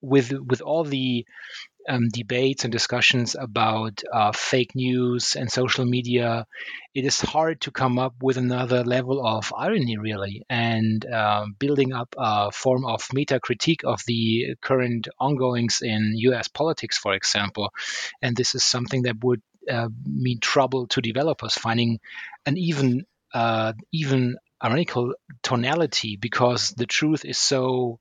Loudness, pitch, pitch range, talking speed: -23 LUFS, 125 Hz, 115-130 Hz, 145 wpm